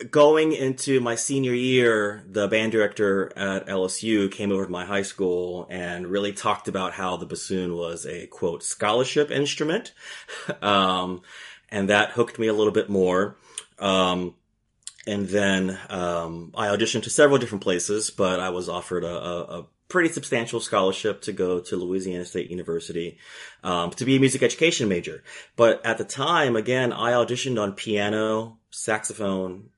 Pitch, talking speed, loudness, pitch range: 100 Hz, 160 wpm, -24 LUFS, 90-115 Hz